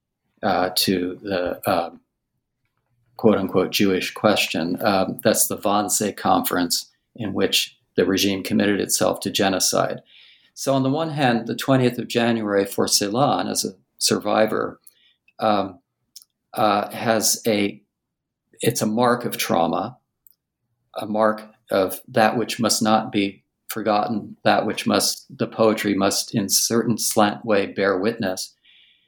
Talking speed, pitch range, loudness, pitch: 135 wpm, 100-120 Hz, -21 LUFS, 110 Hz